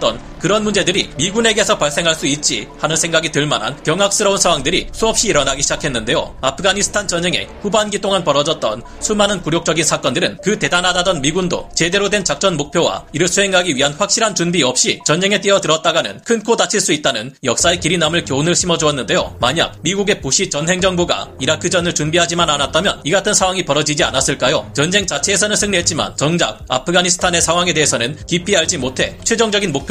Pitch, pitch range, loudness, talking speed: 175 Hz, 155-200 Hz, -15 LUFS, 450 characters per minute